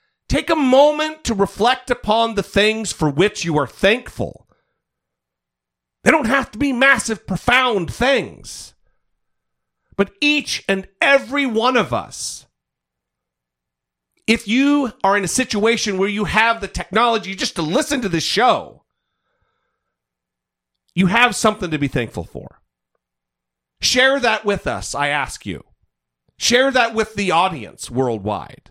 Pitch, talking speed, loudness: 205 Hz, 135 wpm, -17 LUFS